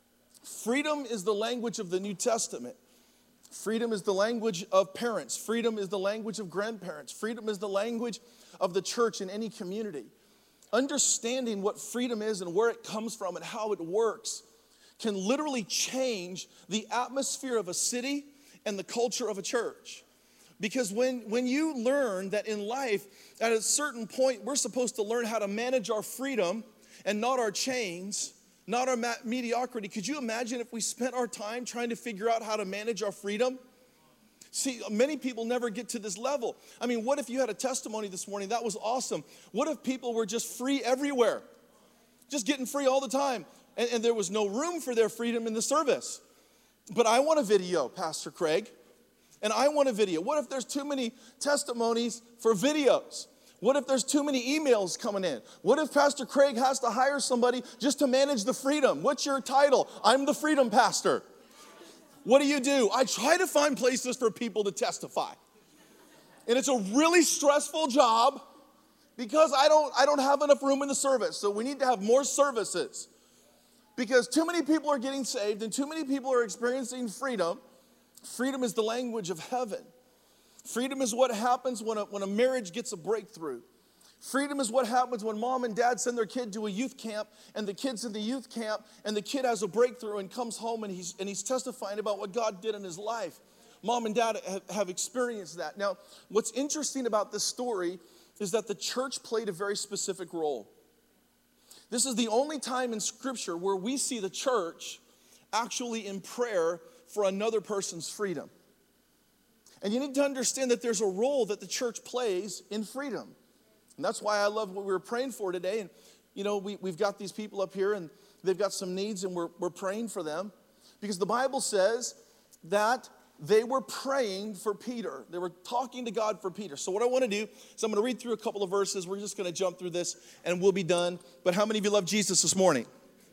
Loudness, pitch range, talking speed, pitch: -30 LUFS, 210-260 Hz, 200 wpm, 235 Hz